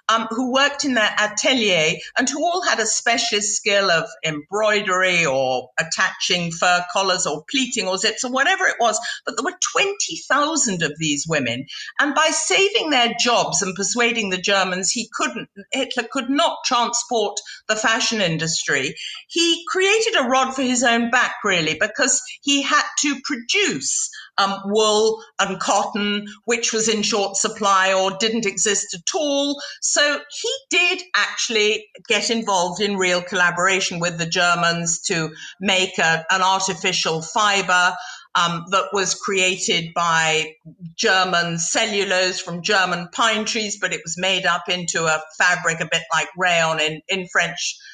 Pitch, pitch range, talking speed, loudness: 205 Hz, 180-240 Hz, 155 wpm, -19 LUFS